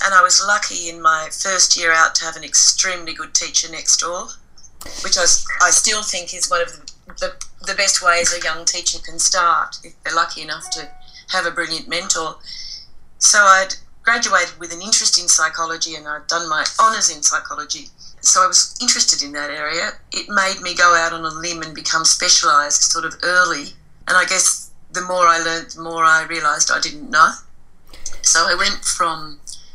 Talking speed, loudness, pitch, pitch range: 200 wpm, -15 LUFS, 175 Hz, 160-185 Hz